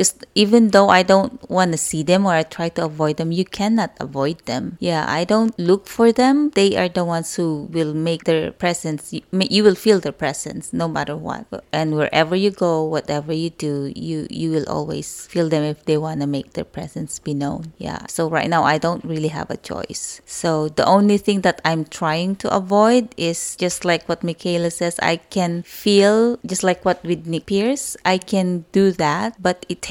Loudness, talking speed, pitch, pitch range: -19 LUFS, 210 wpm, 170 Hz, 160-195 Hz